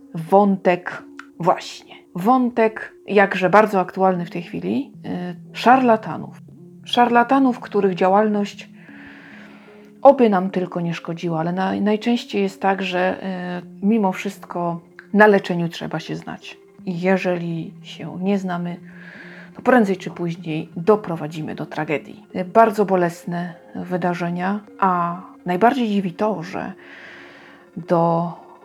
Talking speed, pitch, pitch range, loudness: 105 wpm, 185 Hz, 175-205 Hz, -20 LUFS